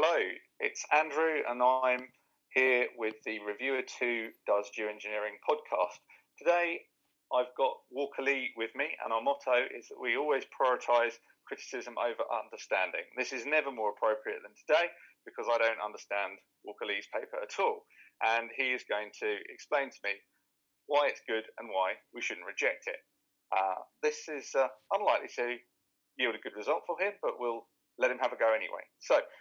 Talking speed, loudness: 175 wpm, -33 LUFS